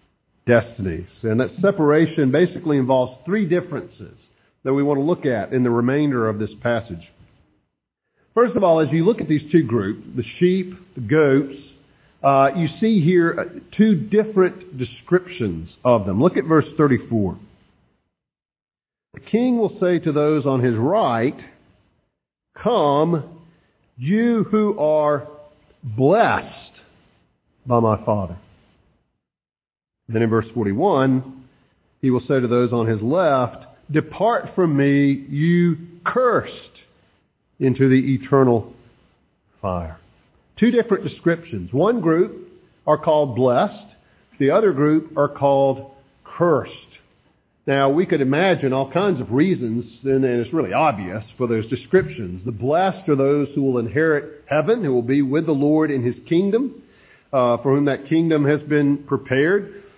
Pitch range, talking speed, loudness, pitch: 125-165 Hz, 140 wpm, -19 LUFS, 140 Hz